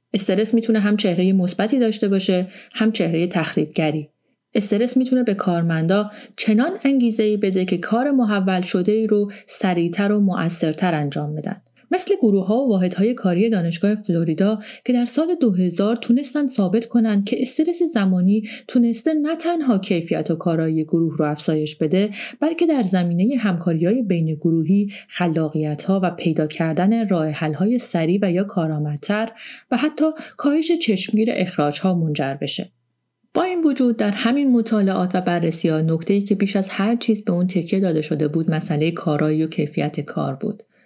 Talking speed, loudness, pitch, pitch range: 165 wpm, -20 LUFS, 195 Hz, 170-230 Hz